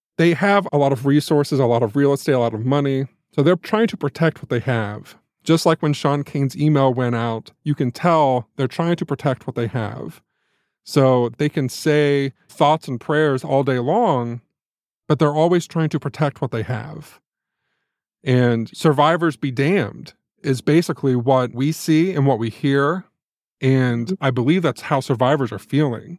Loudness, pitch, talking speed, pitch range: -19 LUFS, 140 Hz, 185 wpm, 130-155 Hz